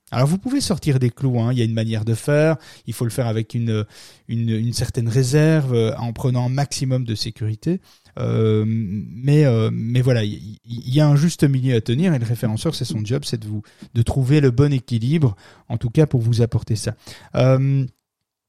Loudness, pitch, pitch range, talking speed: -20 LUFS, 125 Hz, 115-140 Hz, 220 wpm